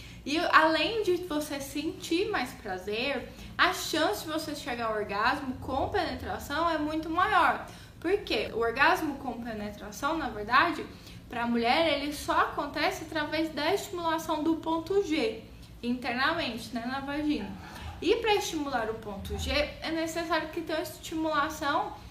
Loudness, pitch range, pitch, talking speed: -29 LUFS, 260-330 Hz, 310 Hz, 145 wpm